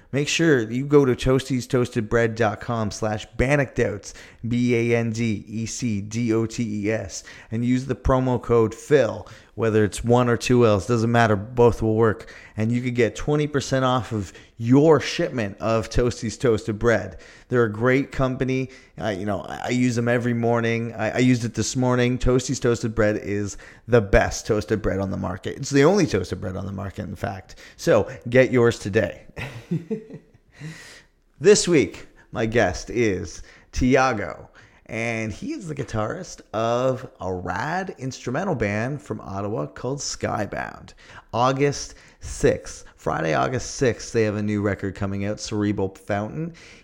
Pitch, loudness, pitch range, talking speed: 115 Hz, -23 LUFS, 105-130 Hz, 165 wpm